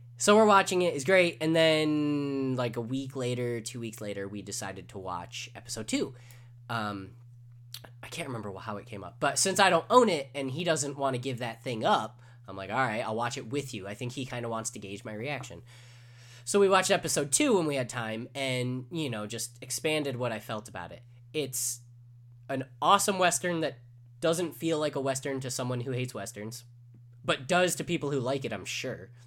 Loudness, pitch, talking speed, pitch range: -29 LUFS, 125 Hz, 215 wpm, 120-145 Hz